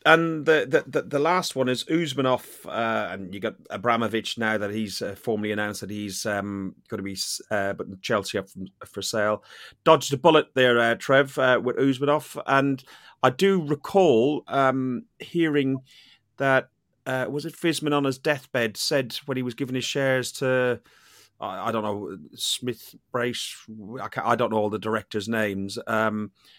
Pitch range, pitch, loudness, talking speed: 110-145 Hz, 130 Hz, -25 LUFS, 180 wpm